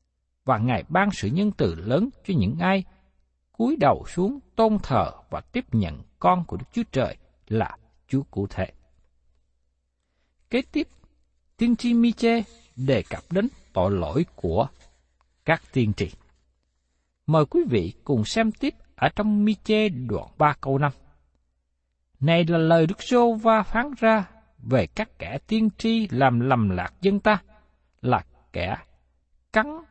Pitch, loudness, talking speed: 135 Hz, -24 LUFS, 150 wpm